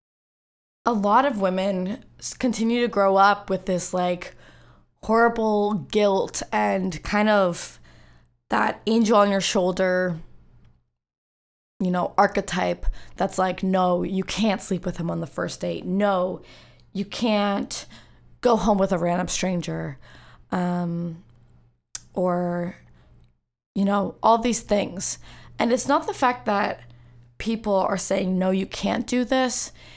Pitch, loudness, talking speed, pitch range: 190 Hz, -23 LUFS, 130 wpm, 175-210 Hz